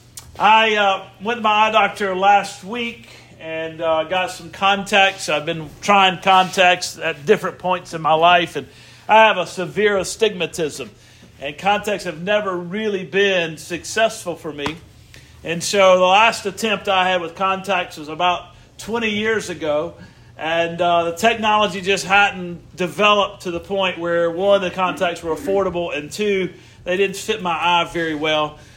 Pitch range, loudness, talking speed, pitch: 165-200 Hz, -18 LUFS, 165 wpm, 185 Hz